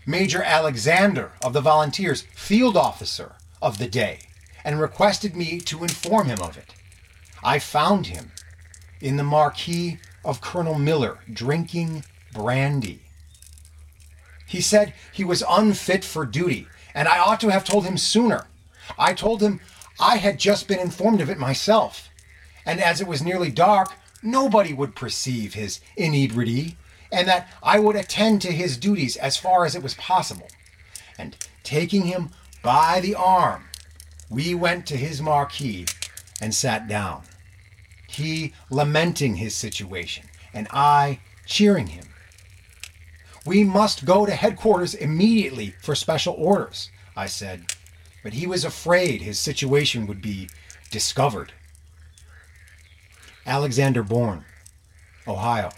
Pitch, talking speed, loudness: 135 Hz, 135 wpm, -22 LUFS